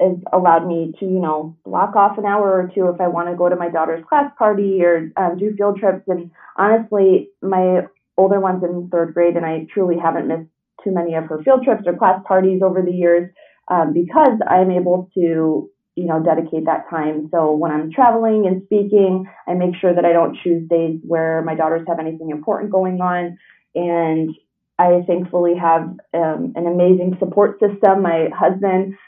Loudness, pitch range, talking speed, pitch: -17 LUFS, 165-190 Hz, 195 wpm, 175 Hz